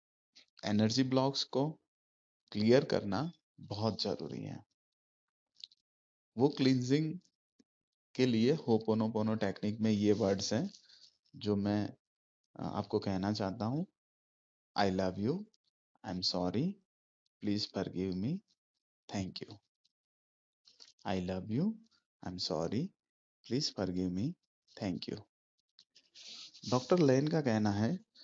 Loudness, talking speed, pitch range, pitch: -34 LUFS, 115 wpm, 95-140 Hz, 110 Hz